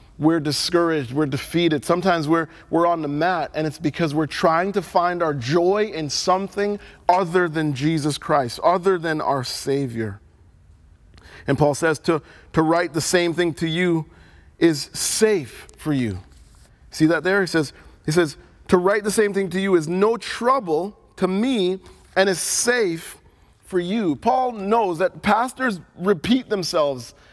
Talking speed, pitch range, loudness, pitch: 165 wpm, 150-190 Hz, -21 LUFS, 170 Hz